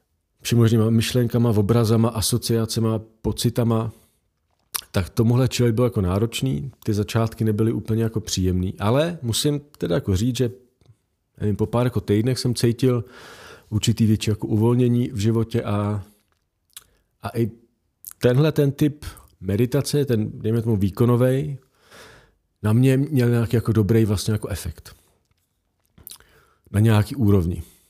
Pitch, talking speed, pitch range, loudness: 115 Hz, 125 wpm, 105-120 Hz, -21 LUFS